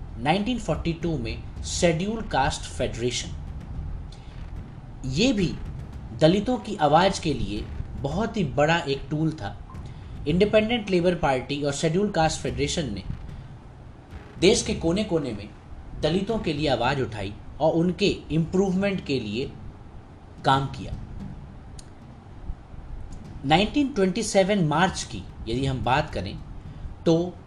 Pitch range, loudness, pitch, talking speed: 110-180 Hz, -25 LUFS, 150 Hz, 110 wpm